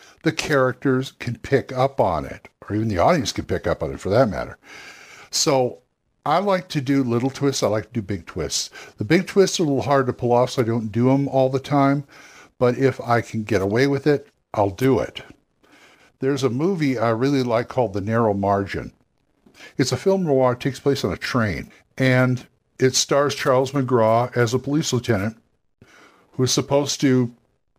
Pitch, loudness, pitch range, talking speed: 130 Hz, -21 LUFS, 120-140 Hz, 205 wpm